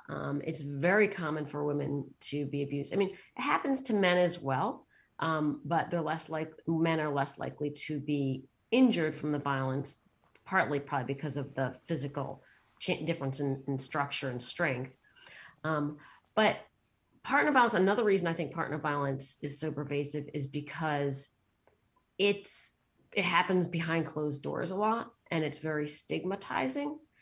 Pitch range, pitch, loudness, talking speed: 140-165 Hz, 150 Hz, -32 LUFS, 160 wpm